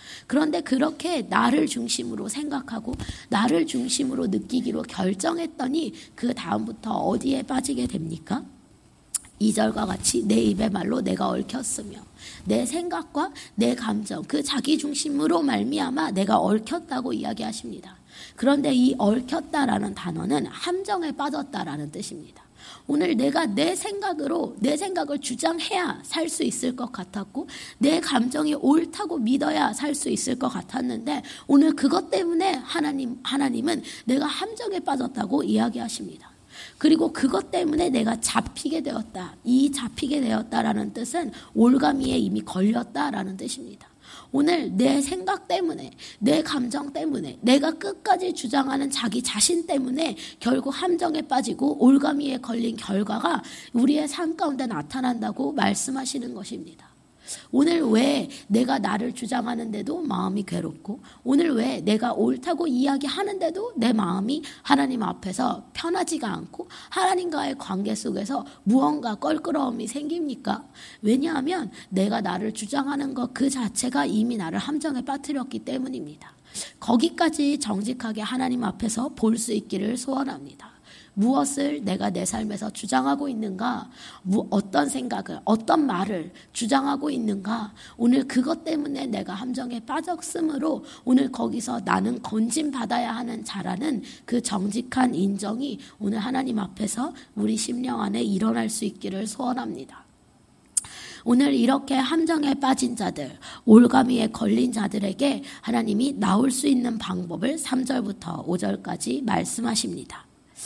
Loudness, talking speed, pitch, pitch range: -25 LUFS, 310 characters per minute, 260 Hz, 230-295 Hz